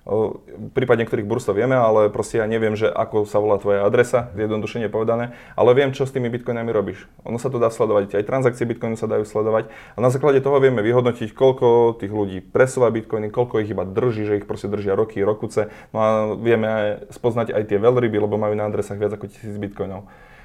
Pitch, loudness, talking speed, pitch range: 110 Hz, -20 LUFS, 210 wpm, 105-120 Hz